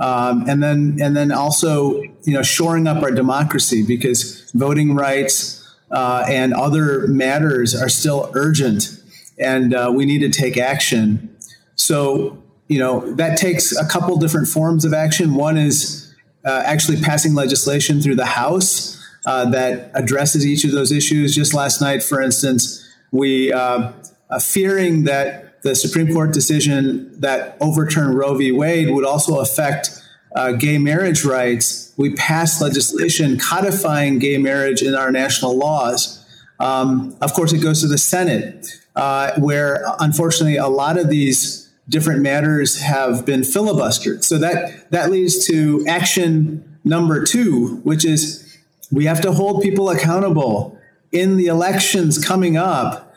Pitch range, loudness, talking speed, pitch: 135-160 Hz, -16 LUFS, 150 wpm, 145 Hz